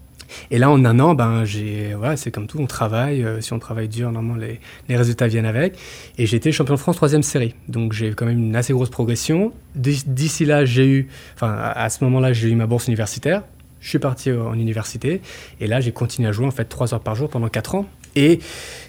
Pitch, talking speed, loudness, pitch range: 120 Hz, 240 wpm, -20 LUFS, 115-140 Hz